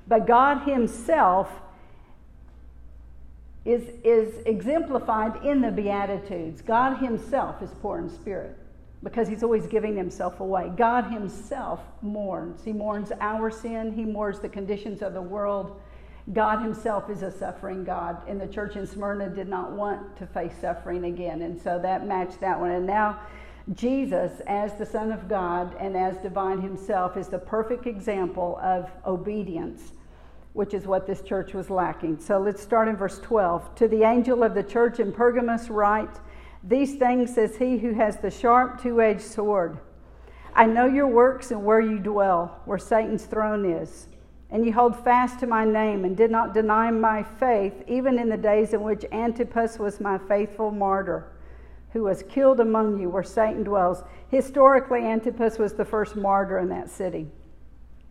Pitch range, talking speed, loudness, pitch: 185-225 Hz, 170 wpm, -25 LUFS, 210 Hz